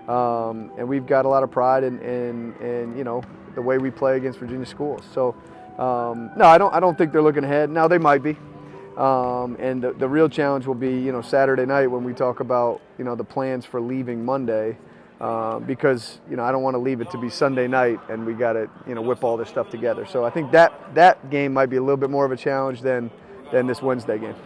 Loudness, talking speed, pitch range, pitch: -21 LUFS, 255 wpm, 120-135 Hz, 130 Hz